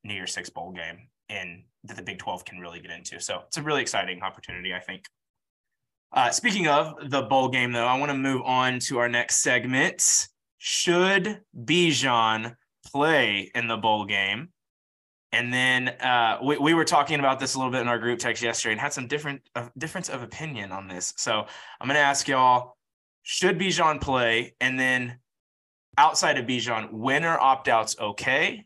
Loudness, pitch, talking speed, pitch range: -24 LUFS, 125 Hz, 190 wpm, 115-145 Hz